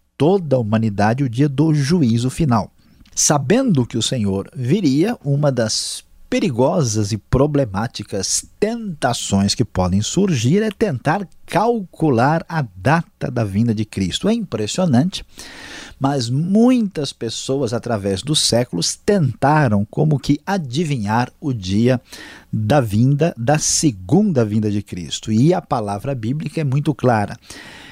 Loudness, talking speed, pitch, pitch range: -18 LUFS, 125 wpm, 135 Hz, 110-160 Hz